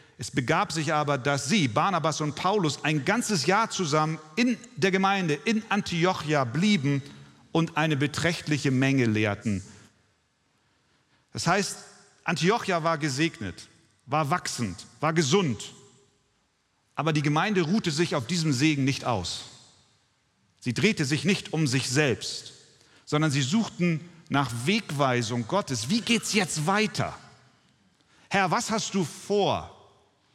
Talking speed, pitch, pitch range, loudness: 130 wpm, 155 Hz, 135-190 Hz, -26 LUFS